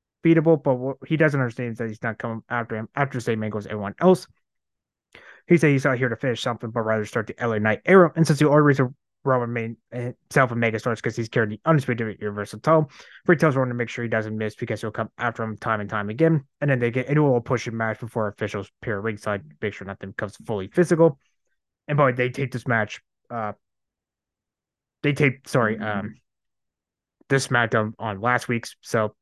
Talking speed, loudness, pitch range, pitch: 220 wpm, -23 LUFS, 110-135 Hz, 120 Hz